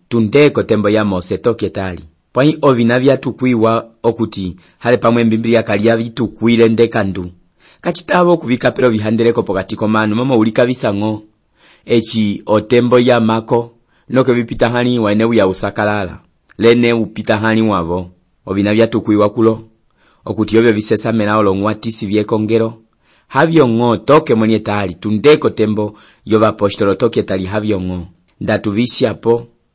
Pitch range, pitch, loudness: 105-120 Hz, 110 Hz, -14 LUFS